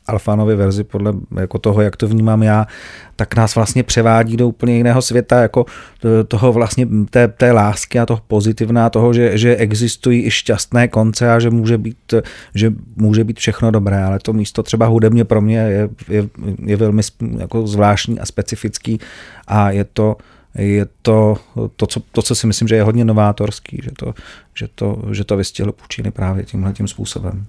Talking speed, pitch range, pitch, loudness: 180 wpm, 105-115 Hz, 110 Hz, -15 LUFS